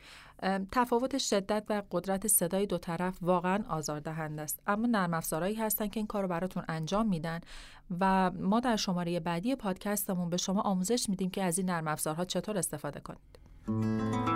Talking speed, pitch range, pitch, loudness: 165 wpm, 165-205 Hz, 185 Hz, -32 LUFS